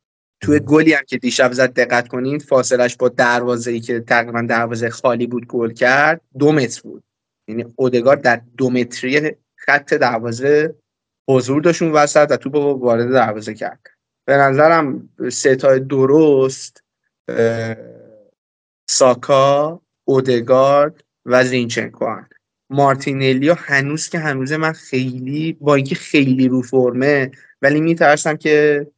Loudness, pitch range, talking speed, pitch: -16 LUFS, 125-150 Hz, 125 wpm, 130 Hz